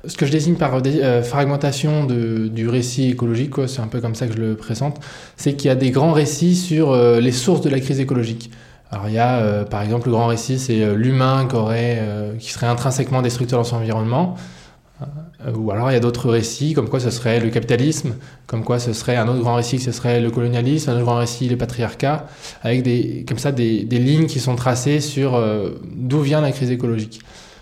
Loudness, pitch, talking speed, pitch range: -19 LUFS, 120 Hz, 240 wpm, 115-140 Hz